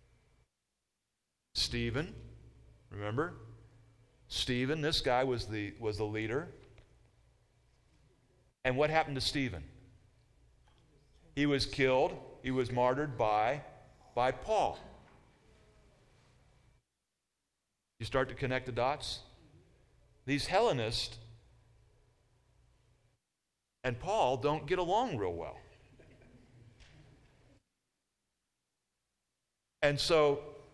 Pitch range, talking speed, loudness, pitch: 115-135 Hz, 80 wpm, -33 LUFS, 125 Hz